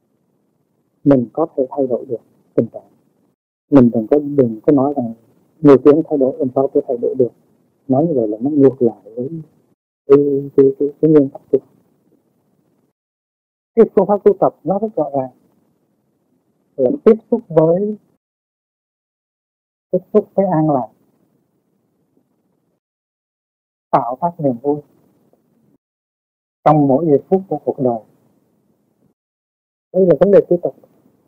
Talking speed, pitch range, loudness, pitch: 145 wpm, 135-175 Hz, -15 LUFS, 145 Hz